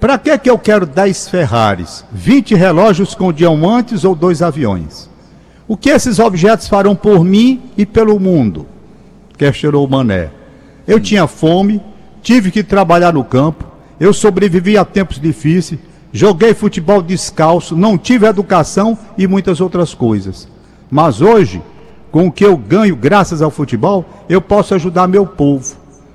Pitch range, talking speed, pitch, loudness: 165-205 Hz, 150 wpm, 190 Hz, -11 LUFS